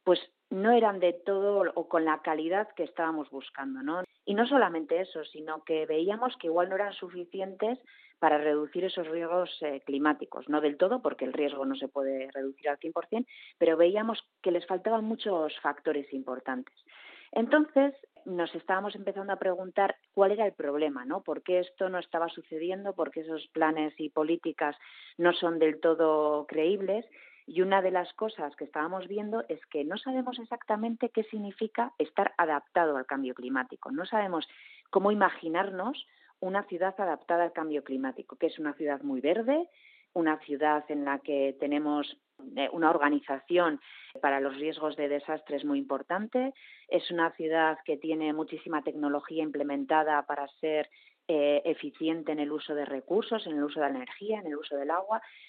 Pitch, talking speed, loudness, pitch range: 165 Hz, 175 wpm, -30 LUFS, 150-195 Hz